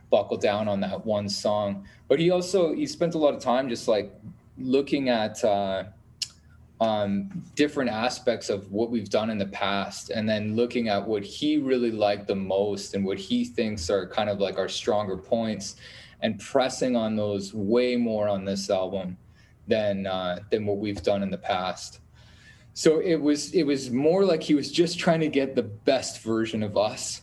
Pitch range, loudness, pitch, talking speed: 100-130 Hz, -26 LUFS, 110 Hz, 190 wpm